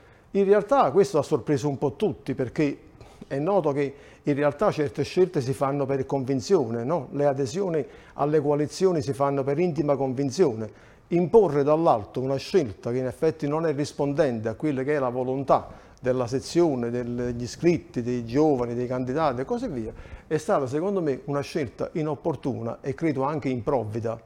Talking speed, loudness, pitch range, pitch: 170 wpm, -25 LUFS, 130-160 Hz, 140 Hz